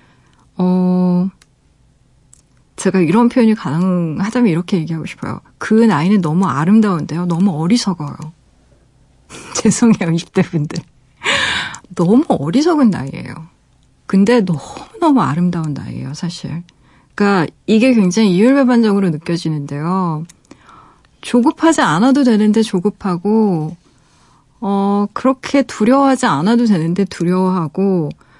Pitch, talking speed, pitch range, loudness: 190 Hz, 275 characters per minute, 165-220 Hz, -15 LUFS